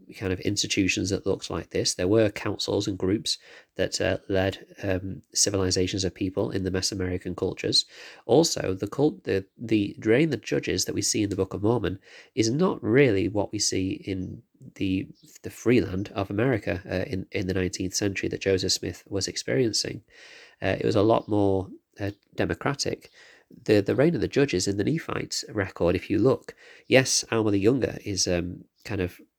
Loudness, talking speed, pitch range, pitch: -26 LUFS, 190 wpm, 95-105 Hz, 100 Hz